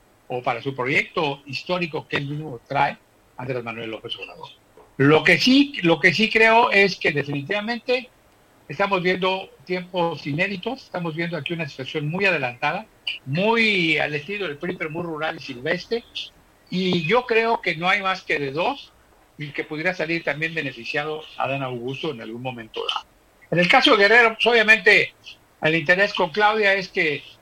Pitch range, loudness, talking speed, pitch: 145-200 Hz, -21 LUFS, 165 wpm, 170 Hz